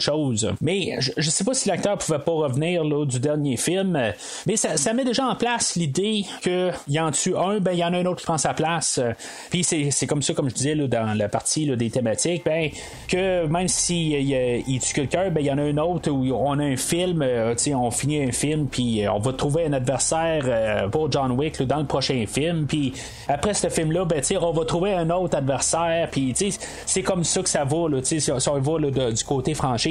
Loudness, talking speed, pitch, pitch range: -23 LUFS, 250 wpm, 155 Hz, 135-175 Hz